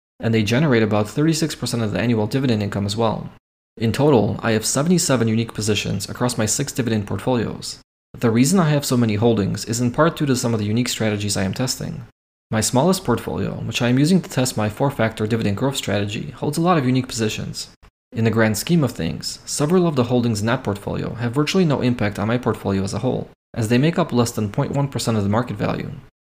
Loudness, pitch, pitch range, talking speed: -20 LUFS, 120 Hz, 110-135 Hz, 225 wpm